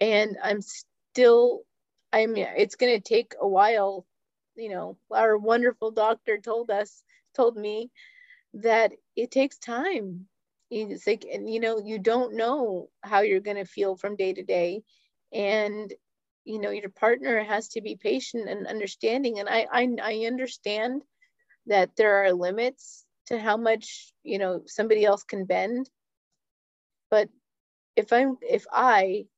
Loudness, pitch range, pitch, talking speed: -25 LUFS, 205-250 Hz, 220 Hz, 150 wpm